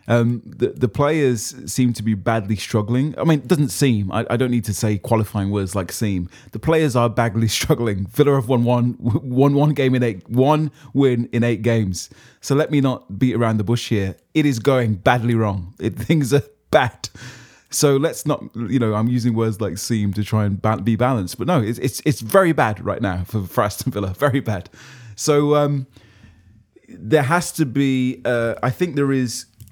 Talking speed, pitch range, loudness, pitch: 205 wpm, 110-140 Hz, -19 LUFS, 120 Hz